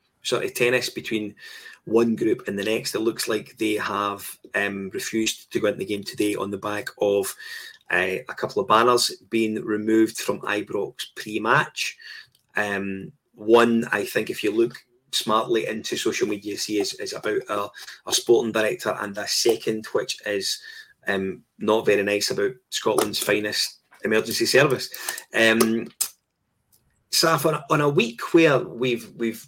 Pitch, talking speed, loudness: 115 Hz, 160 wpm, -23 LUFS